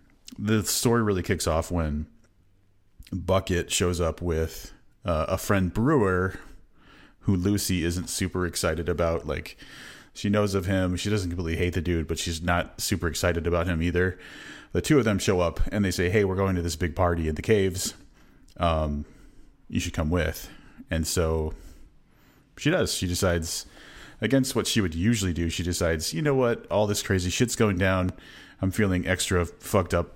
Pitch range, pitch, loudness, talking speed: 85-100 Hz, 90 Hz, -26 LUFS, 180 wpm